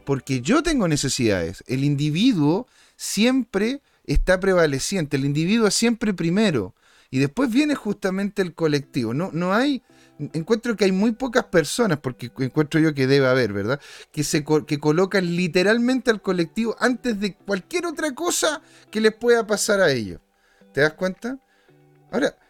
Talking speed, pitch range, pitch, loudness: 150 wpm, 145-230 Hz, 185 Hz, -22 LUFS